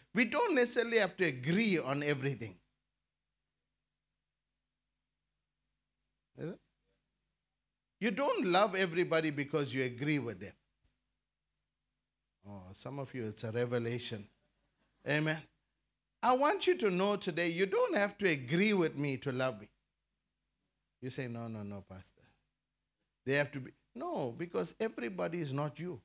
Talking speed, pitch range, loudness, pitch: 130 wpm, 125-185 Hz, -34 LUFS, 145 Hz